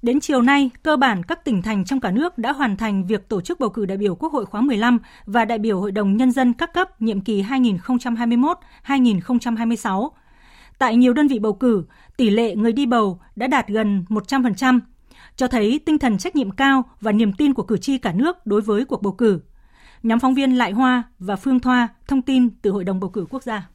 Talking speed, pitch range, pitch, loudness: 225 wpm, 215-265 Hz, 240 Hz, -20 LUFS